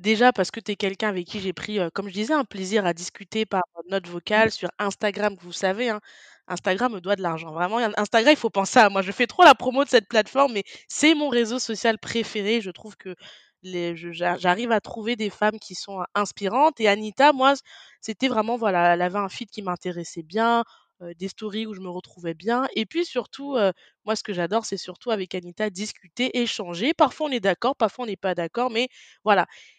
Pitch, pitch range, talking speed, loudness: 210 Hz, 185-235 Hz, 225 wpm, -23 LUFS